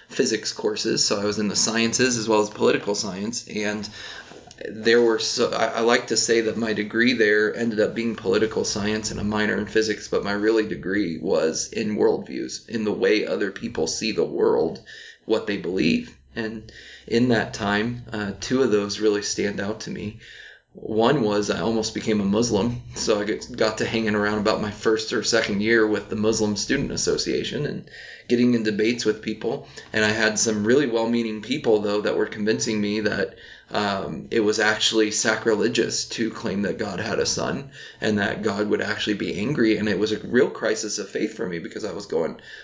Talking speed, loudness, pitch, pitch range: 200 wpm, -23 LUFS, 110 Hz, 105-115 Hz